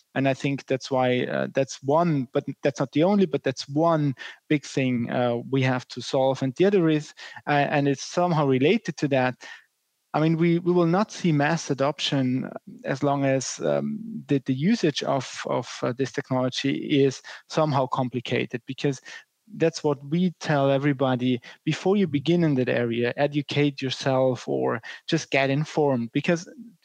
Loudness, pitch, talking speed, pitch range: -24 LUFS, 140 Hz, 170 wpm, 130-160 Hz